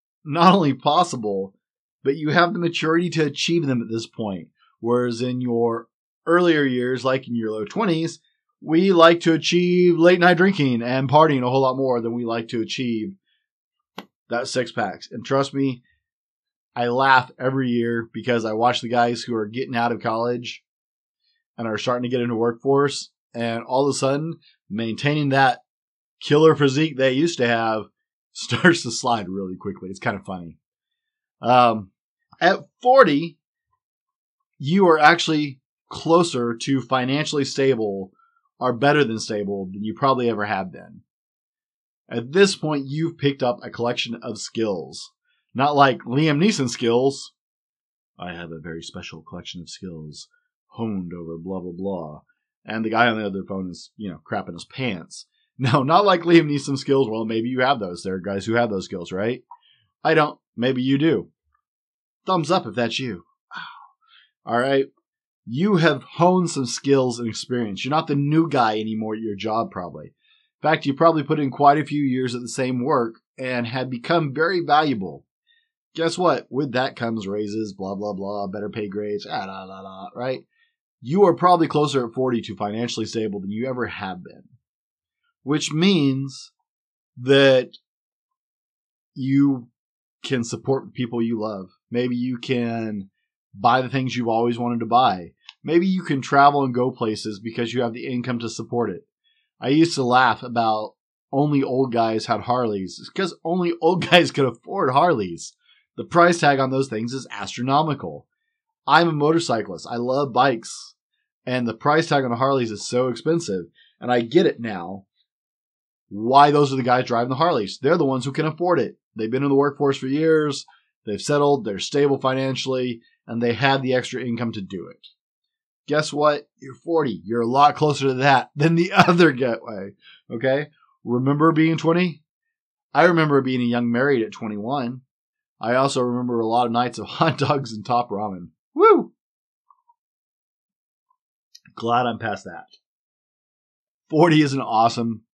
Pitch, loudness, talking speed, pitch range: 130 Hz, -21 LUFS, 175 wpm, 115-160 Hz